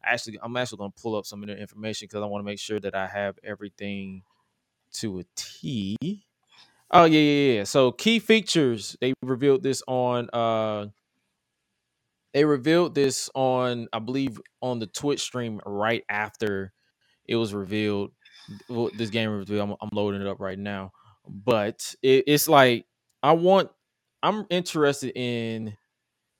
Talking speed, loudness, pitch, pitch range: 160 wpm, -25 LUFS, 115 Hz, 105-135 Hz